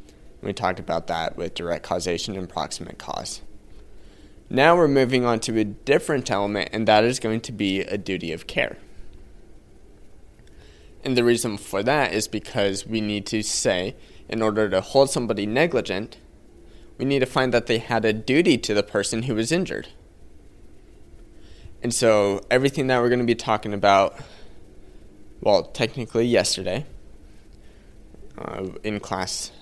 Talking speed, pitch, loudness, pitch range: 155 wpm, 110 Hz, -23 LUFS, 100-120 Hz